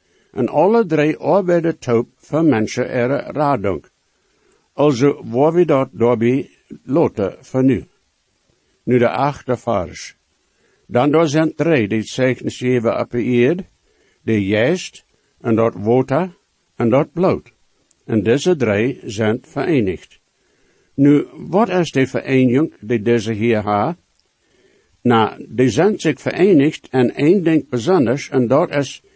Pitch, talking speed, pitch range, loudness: 130 Hz, 130 wpm, 120-155 Hz, -17 LUFS